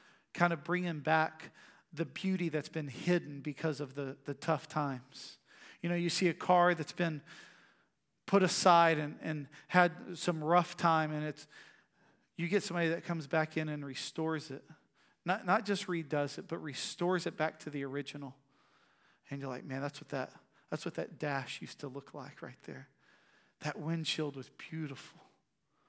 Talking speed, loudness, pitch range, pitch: 175 wpm, -34 LUFS, 145-175 Hz, 160 Hz